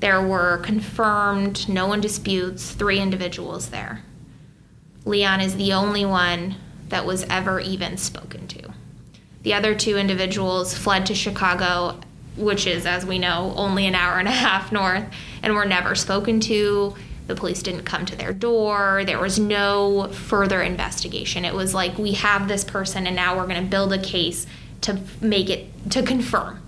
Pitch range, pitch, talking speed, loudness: 185-205 Hz, 195 Hz, 170 wpm, -21 LUFS